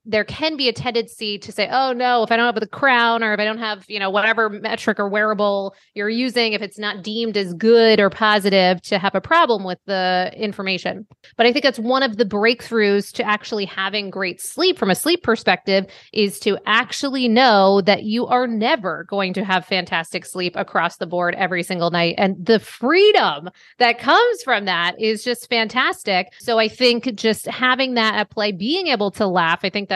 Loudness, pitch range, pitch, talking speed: -18 LUFS, 195-240 Hz, 215 Hz, 210 wpm